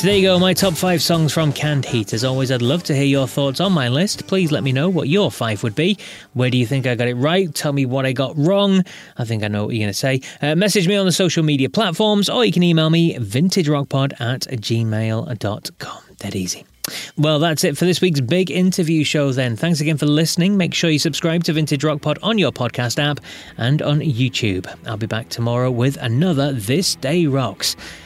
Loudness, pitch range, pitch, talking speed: -18 LUFS, 125-175 Hz, 150 Hz, 235 wpm